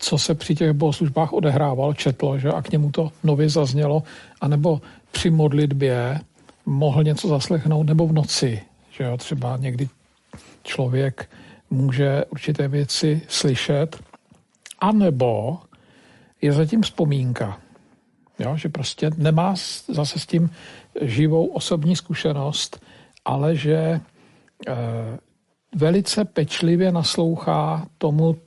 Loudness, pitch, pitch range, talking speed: -21 LUFS, 155 Hz, 140-165 Hz, 110 wpm